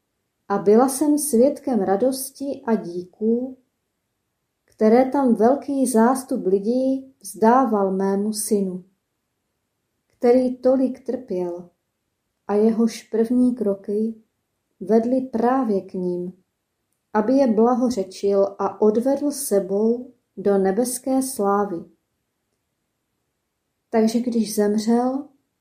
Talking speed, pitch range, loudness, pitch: 90 wpm, 200-255 Hz, -21 LUFS, 225 Hz